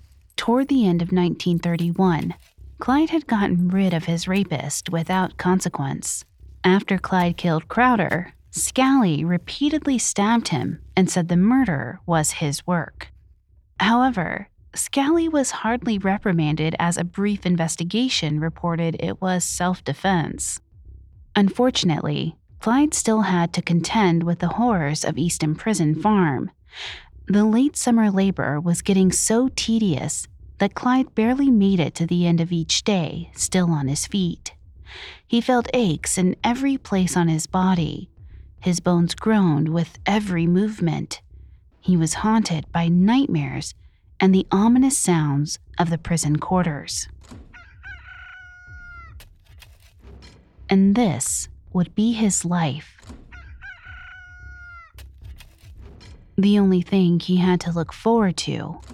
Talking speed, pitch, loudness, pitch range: 125 wpm, 180 Hz, -21 LUFS, 165-220 Hz